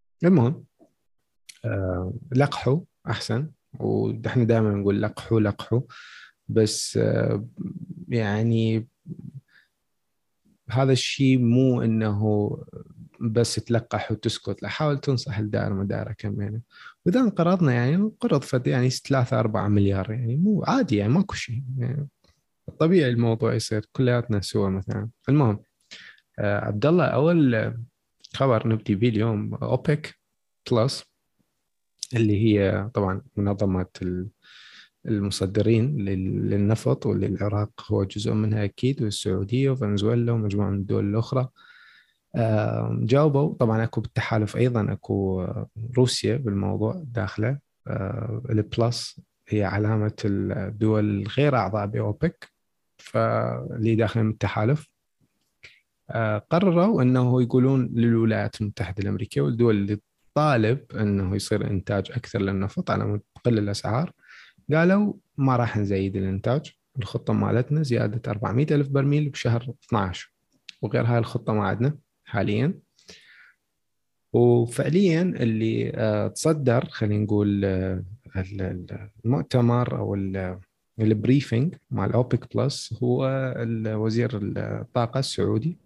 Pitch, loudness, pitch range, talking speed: 115 Hz, -24 LUFS, 105-130 Hz, 100 wpm